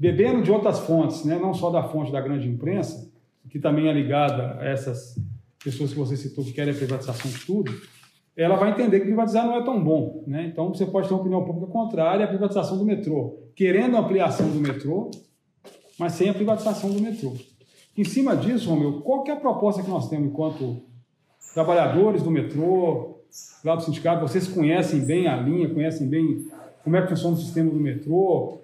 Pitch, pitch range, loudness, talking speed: 165 Hz, 145-195 Hz, -23 LUFS, 200 wpm